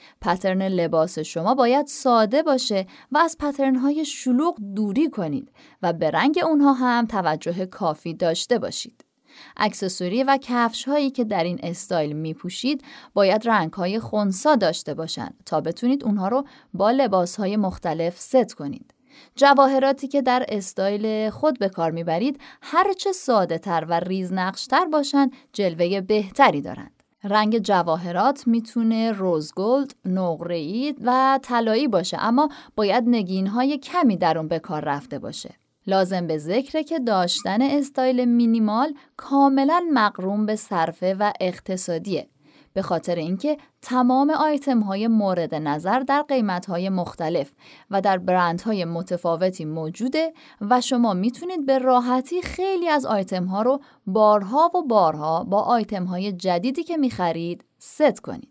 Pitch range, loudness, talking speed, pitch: 185-270 Hz, -22 LUFS, 145 wpm, 220 Hz